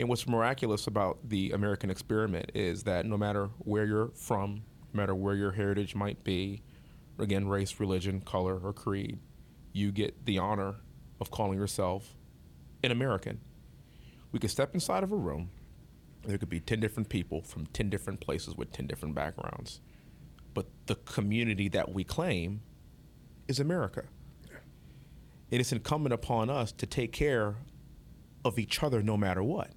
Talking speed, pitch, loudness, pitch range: 160 wpm, 105 Hz, -33 LUFS, 100-115 Hz